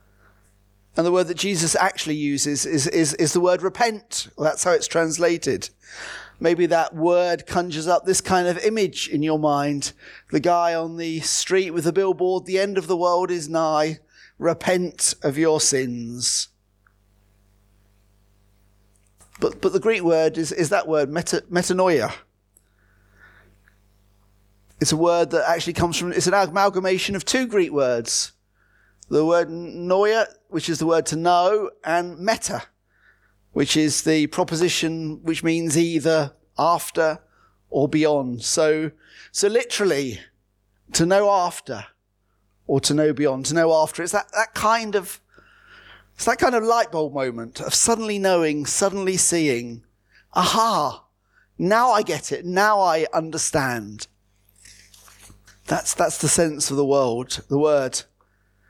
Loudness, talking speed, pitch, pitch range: -21 LUFS, 145 wpm, 160 Hz, 120-180 Hz